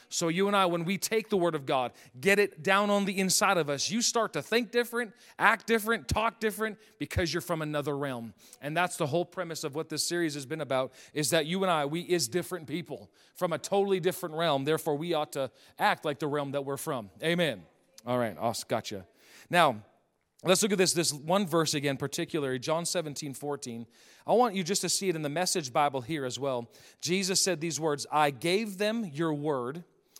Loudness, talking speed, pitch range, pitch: -29 LUFS, 220 wpm, 145-190 Hz, 170 Hz